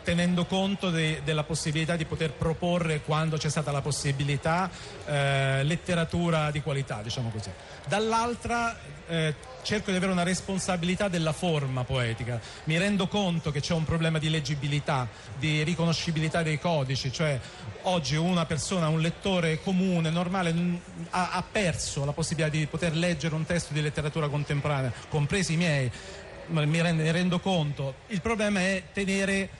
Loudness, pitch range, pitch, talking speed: -28 LUFS, 150-175 Hz, 160 Hz, 155 wpm